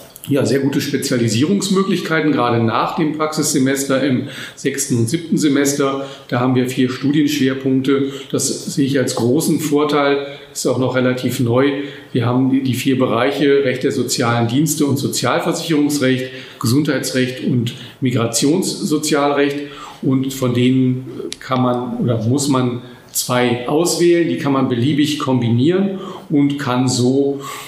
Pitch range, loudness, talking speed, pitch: 125-145 Hz, -17 LUFS, 130 wpm, 135 Hz